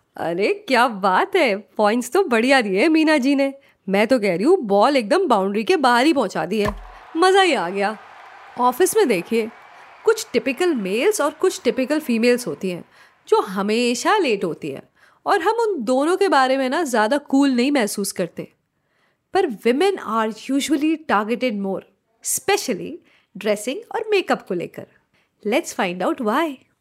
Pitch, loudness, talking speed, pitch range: 260 Hz, -19 LUFS, 170 wpm, 215-335 Hz